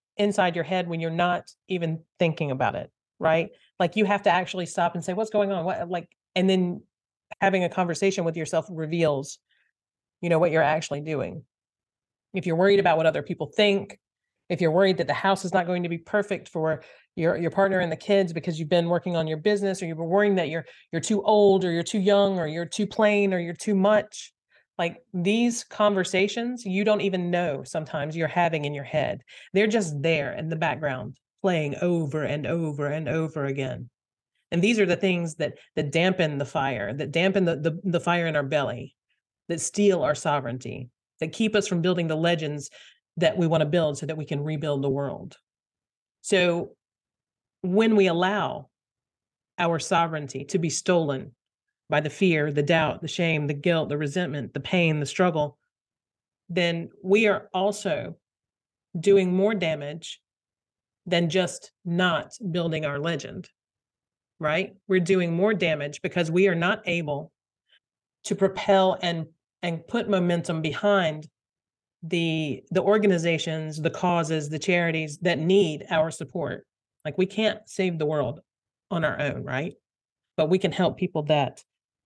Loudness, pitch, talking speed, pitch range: -25 LUFS, 170 Hz, 175 wpm, 155-190 Hz